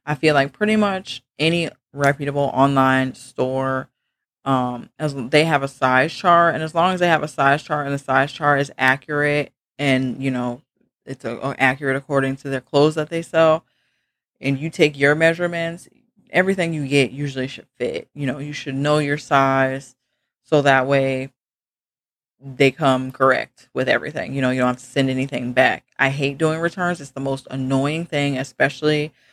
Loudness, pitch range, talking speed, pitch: -20 LUFS, 130-150 Hz, 185 wpm, 140 Hz